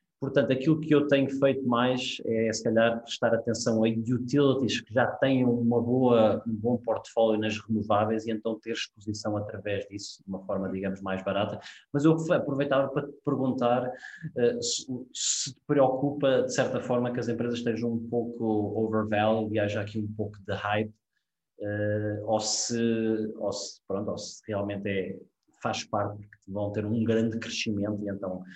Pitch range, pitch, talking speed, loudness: 105-125 Hz, 115 Hz, 175 wpm, -28 LUFS